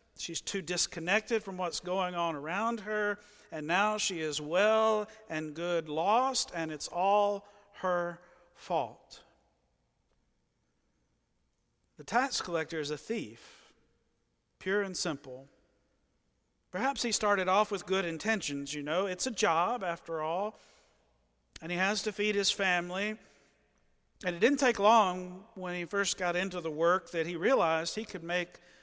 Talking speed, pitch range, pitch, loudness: 145 wpm, 165-210 Hz, 180 Hz, -31 LUFS